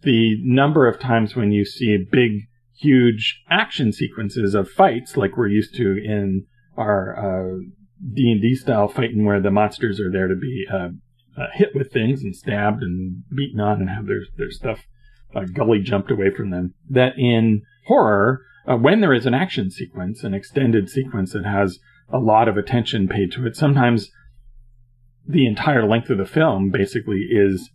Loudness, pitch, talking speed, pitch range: -19 LUFS, 115 Hz, 175 wpm, 100-125 Hz